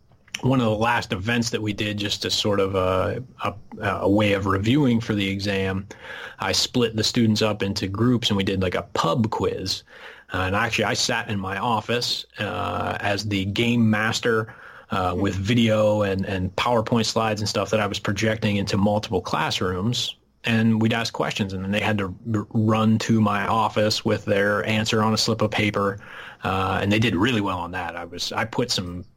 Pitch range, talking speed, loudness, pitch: 100-115 Hz, 205 wpm, -23 LUFS, 105 Hz